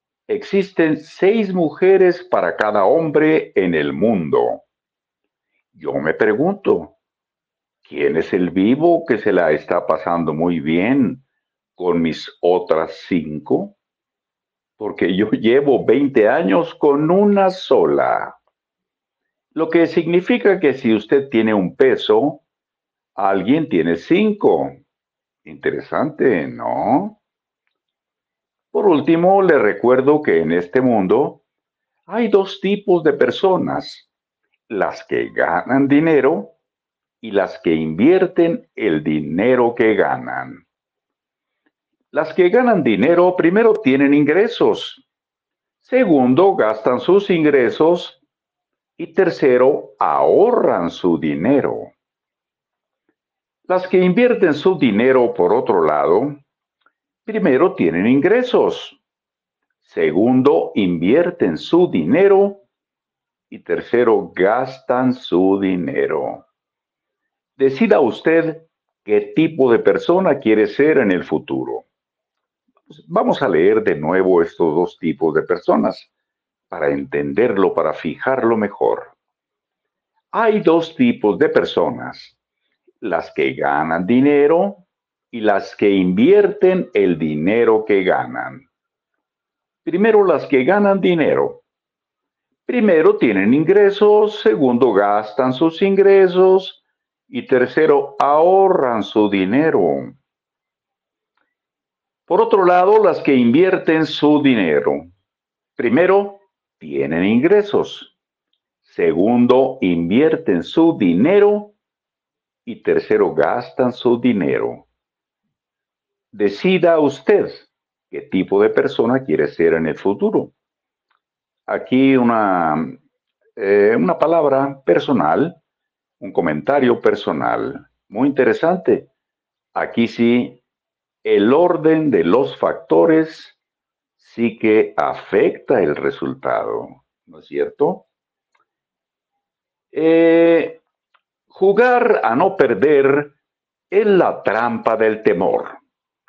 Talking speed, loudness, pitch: 95 wpm, -16 LUFS, 185 Hz